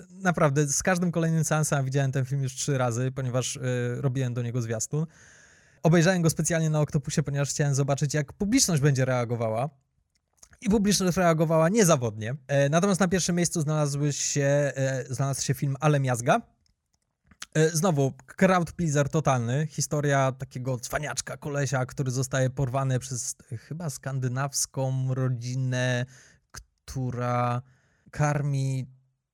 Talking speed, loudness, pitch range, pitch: 135 wpm, -26 LUFS, 130-155 Hz, 140 Hz